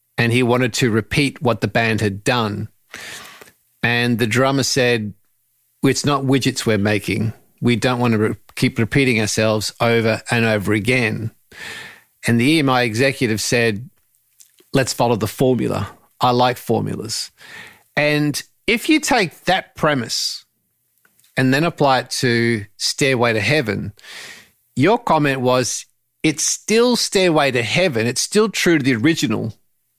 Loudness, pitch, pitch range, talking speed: -18 LUFS, 125 Hz, 115-140 Hz, 140 wpm